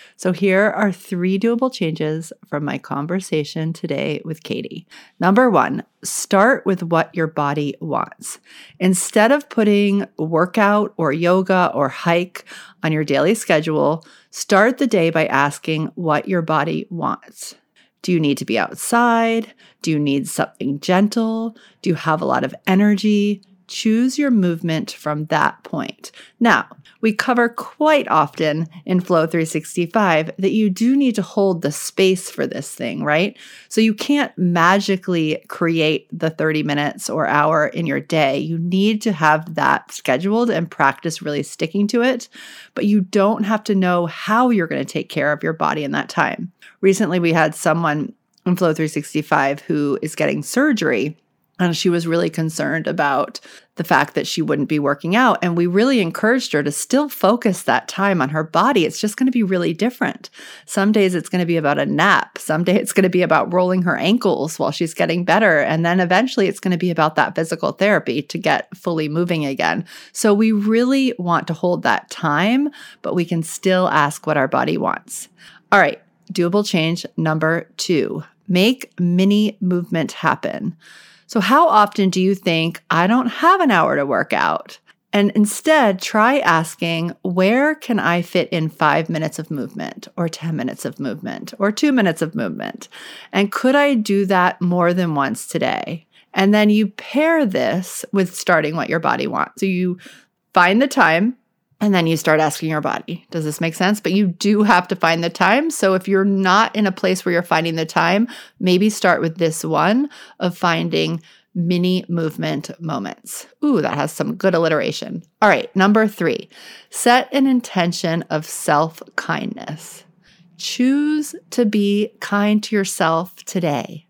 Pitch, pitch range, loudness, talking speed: 185 Hz, 165-215 Hz, -18 LUFS, 175 wpm